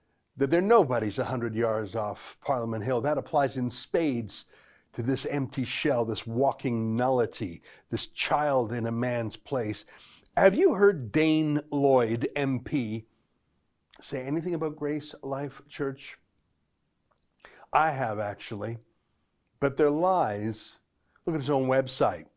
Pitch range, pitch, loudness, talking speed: 115-145 Hz, 130 Hz, -28 LUFS, 135 wpm